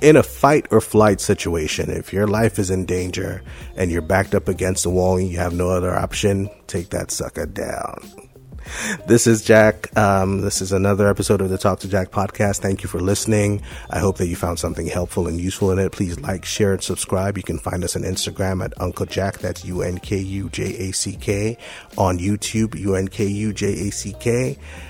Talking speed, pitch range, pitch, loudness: 185 wpm, 90-105 Hz, 95 Hz, -20 LUFS